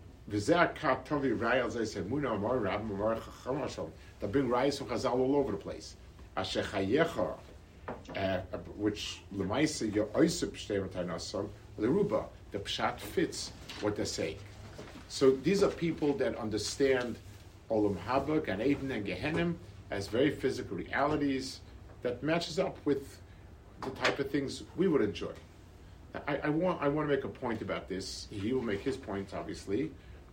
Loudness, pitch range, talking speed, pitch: -33 LUFS, 95-135 Hz, 150 wpm, 105 Hz